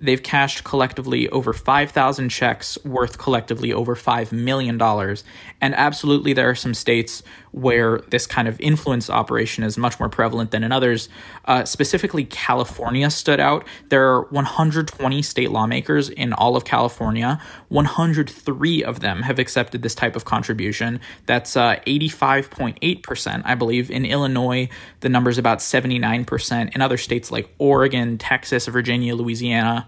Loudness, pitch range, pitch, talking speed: -20 LUFS, 115-135 Hz, 125 Hz, 145 wpm